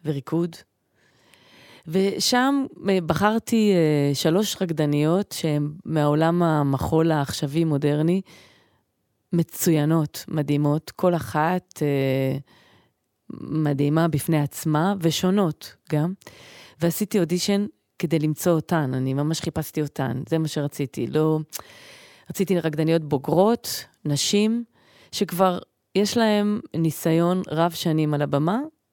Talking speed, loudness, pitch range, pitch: 95 wpm, -23 LUFS, 150-185 Hz, 160 Hz